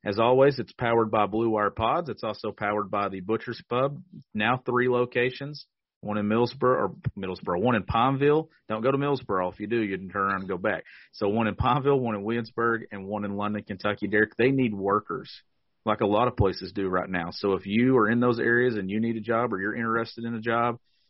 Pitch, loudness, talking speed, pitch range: 115 Hz, -26 LUFS, 235 wpm, 105-125 Hz